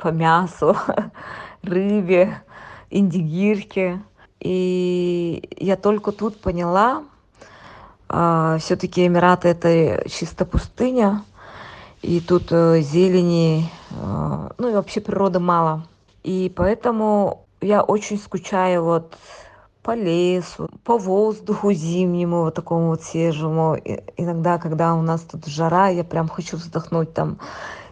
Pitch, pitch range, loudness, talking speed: 180 Hz, 165-195 Hz, -20 LUFS, 110 wpm